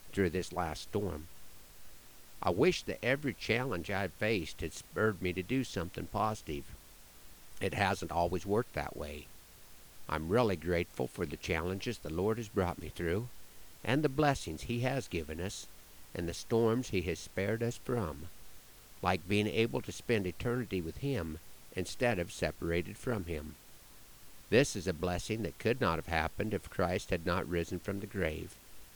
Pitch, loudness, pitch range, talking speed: 95 Hz, -35 LUFS, 85-110 Hz, 170 wpm